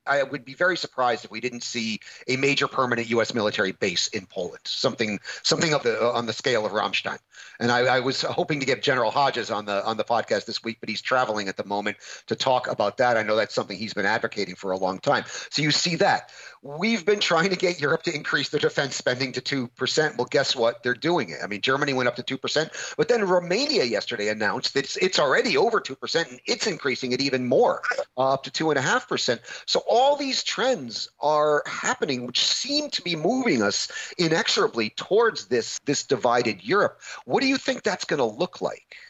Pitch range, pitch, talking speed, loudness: 115-180 Hz, 135 Hz, 230 wpm, -24 LUFS